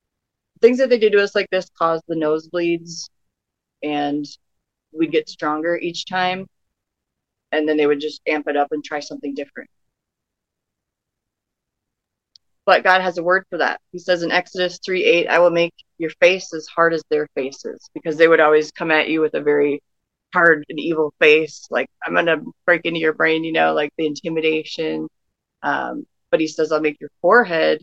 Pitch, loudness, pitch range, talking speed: 160 Hz, -19 LUFS, 150-175 Hz, 190 wpm